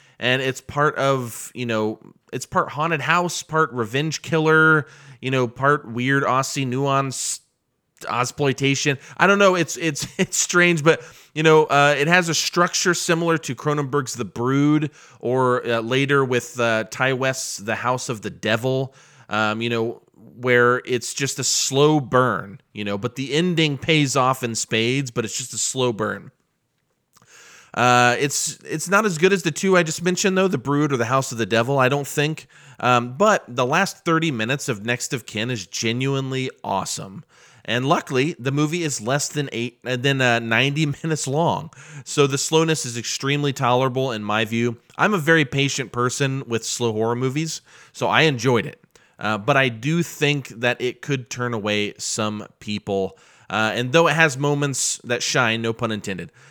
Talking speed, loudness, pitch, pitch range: 185 wpm, -21 LUFS, 135 Hz, 120-150 Hz